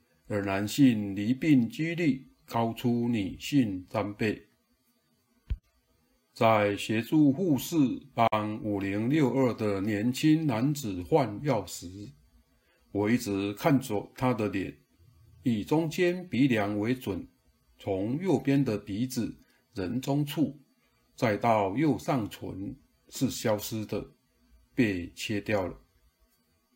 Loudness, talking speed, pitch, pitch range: -29 LUFS, 150 characters per minute, 115 Hz, 105-135 Hz